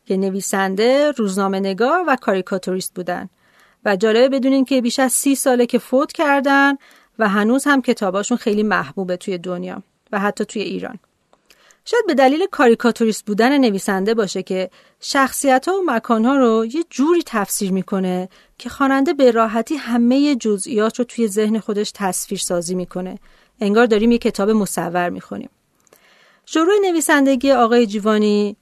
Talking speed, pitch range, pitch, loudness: 150 wpm, 200-265 Hz, 225 Hz, -17 LUFS